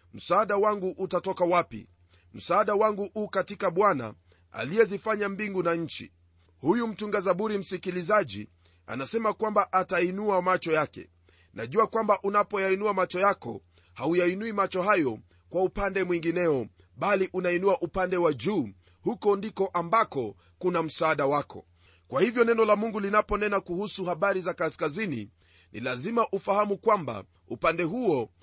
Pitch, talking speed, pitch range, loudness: 185 Hz, 130 wpm, 125-205 Hz, -27 LUFS